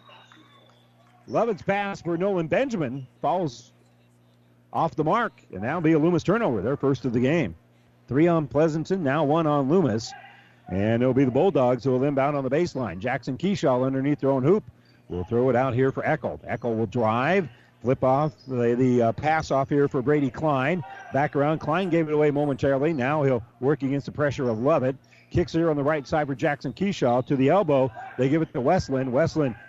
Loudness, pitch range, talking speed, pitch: -24 LUFS, 125-160 Hz, 200 wpm, 140 Hz